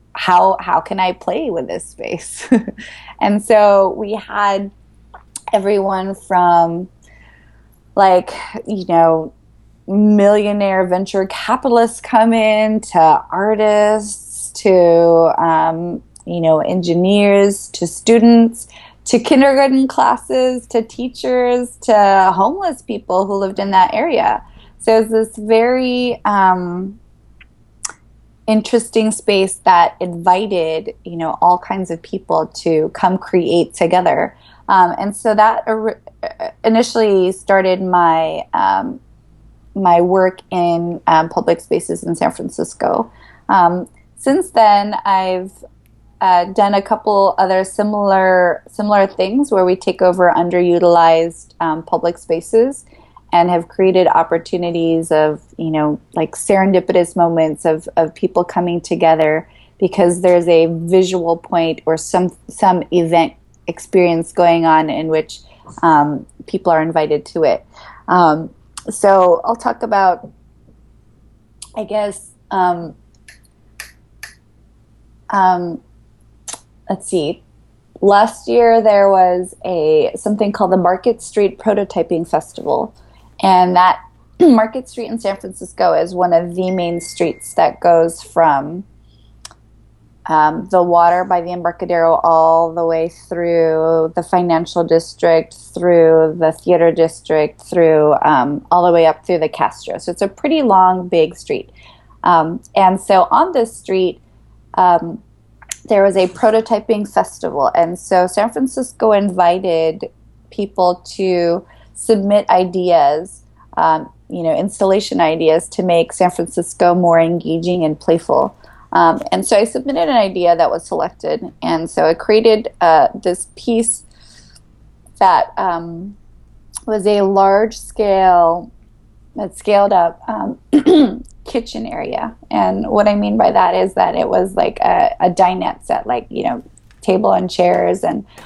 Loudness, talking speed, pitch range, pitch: -14 LUFS, 125 wpm, 170-210 Hz, 185 Hz